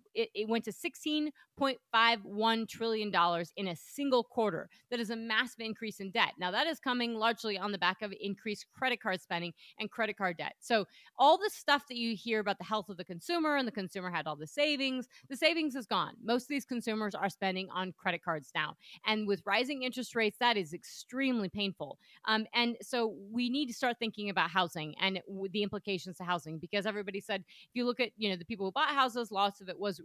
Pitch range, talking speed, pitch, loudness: 195-245 Hz, 220 wpm, 215 Hz, -33 LUFS